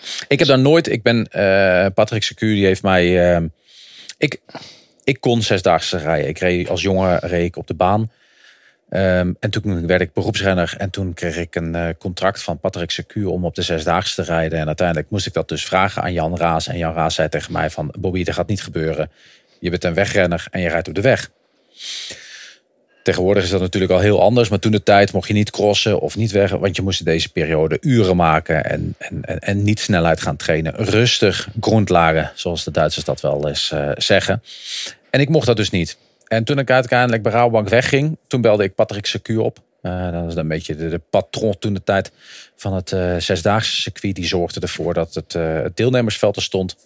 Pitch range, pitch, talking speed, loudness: 85-110 Hz, 95 Hz, 220 wpm, -18 LUFS